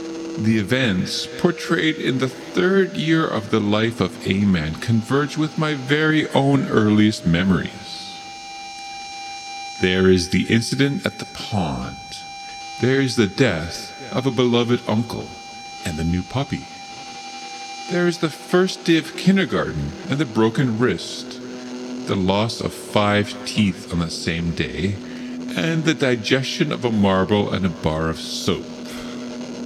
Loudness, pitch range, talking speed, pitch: -21 LUFS, 105-160 Hz, 140 wpm, 125 Hz